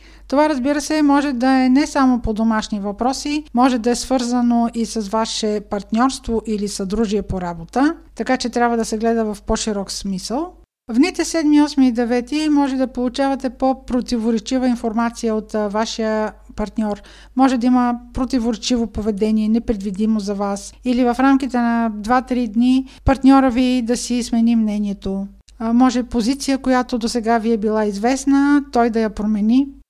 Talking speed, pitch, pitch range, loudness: 160 wpm, 240 Hz, 220-260 Hz, -18 LUFS